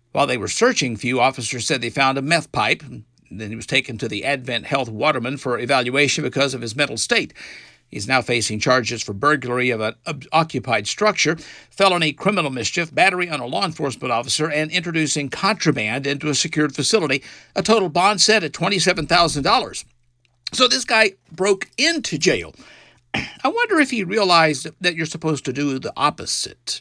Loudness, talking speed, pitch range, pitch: -19 LUFS, 175 wpm, 125-175 Hz, 145 Hz